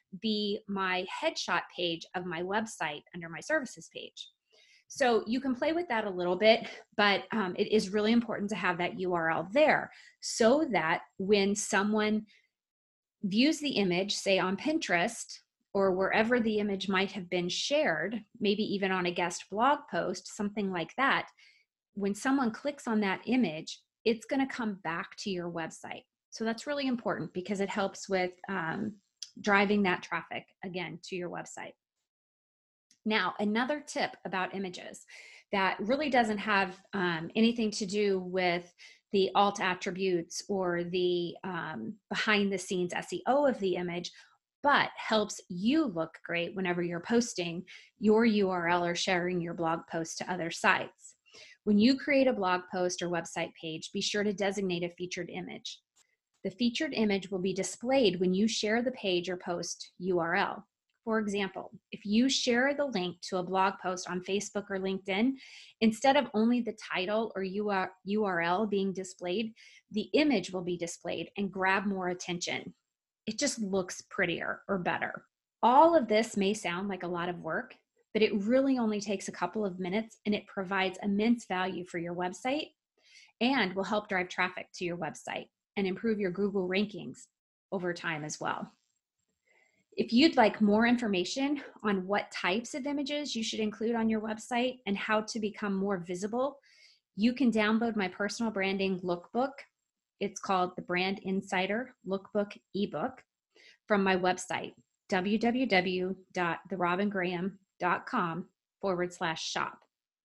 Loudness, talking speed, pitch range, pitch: -31 LUFS, 160 wpm, 185-220 Hz, 200 Hz